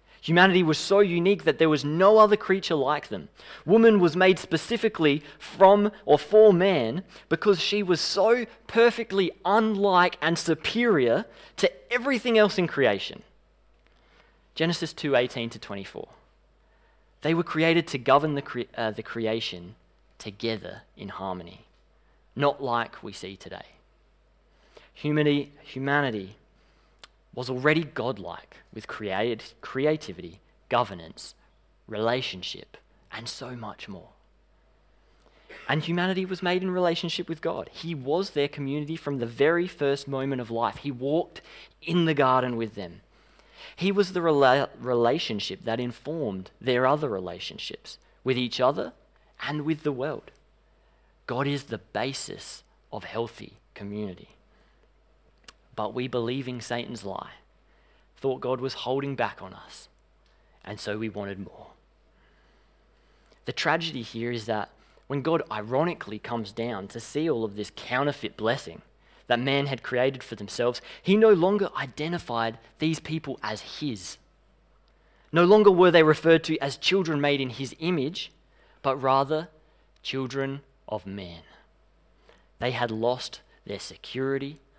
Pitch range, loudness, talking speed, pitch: 120-170 Hz, -25 LUFS, 135 wpm, 140 Hz